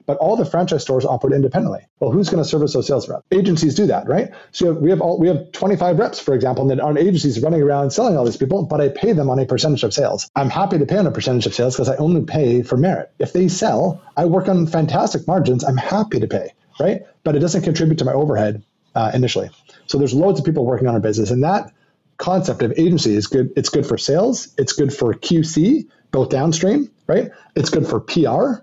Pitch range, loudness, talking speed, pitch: 135-180 Hz, -18 LUFS, 250 wpm, 155 Hz